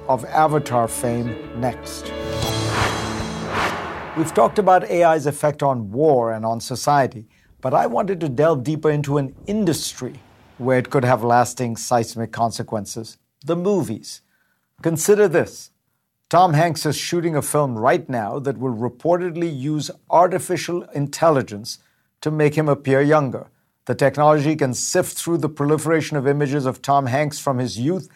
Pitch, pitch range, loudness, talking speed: 140 Hz, 120-155 Hz, -20 LUFS, 145 wpm